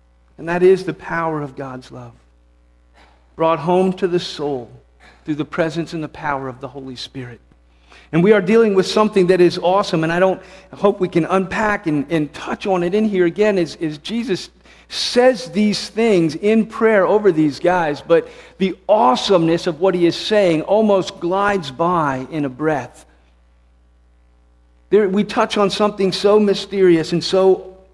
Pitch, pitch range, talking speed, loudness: 175 Hz, 135-195 Hz, 175 wpm, -17 LUFS